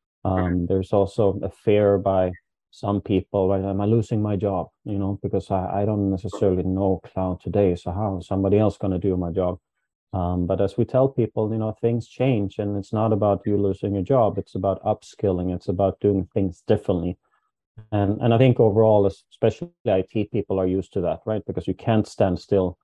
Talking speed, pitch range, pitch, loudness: 205 wpm, 95-105 Hz, 100 Hz, -23 LUFS